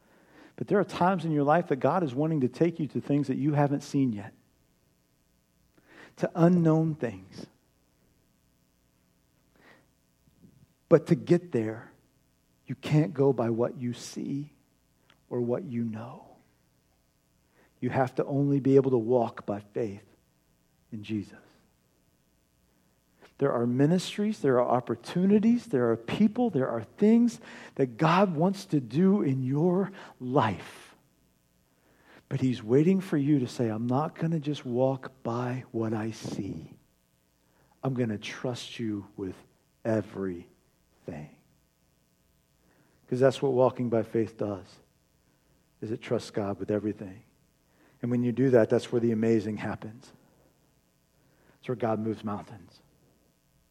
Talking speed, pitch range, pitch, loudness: 135 wpm, 95-140 Hz, 120 Hz, -28 LUFS